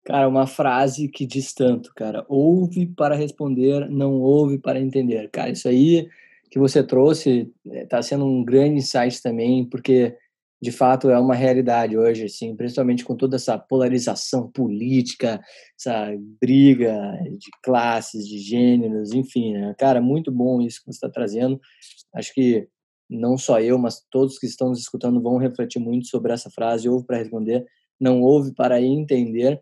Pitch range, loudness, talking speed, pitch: 120-135 Hz, -20 LUFS, 160 wpm, 125 Hz